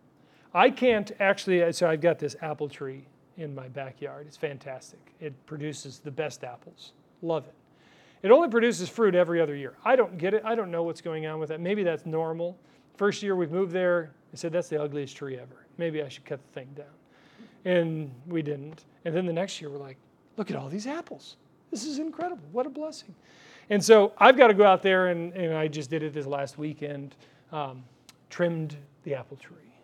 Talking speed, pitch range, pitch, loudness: 210 wpm, 145-195 Hz, 160 Hz, -26 LUFS